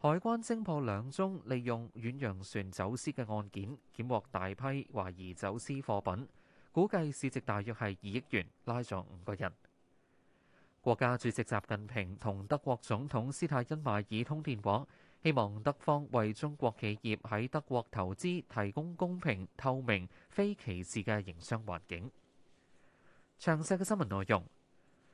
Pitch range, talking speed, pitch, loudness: 100-140 Hz, 230 characters per minute, 120 Hz, -37 LUFS